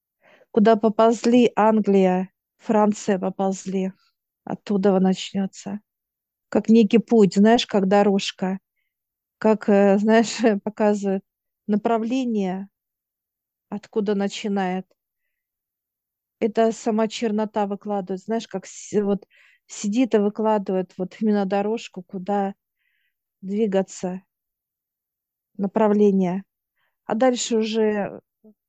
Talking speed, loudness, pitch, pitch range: 80 wpm, -21 LUFS, 210 Hz, 195-225 Hz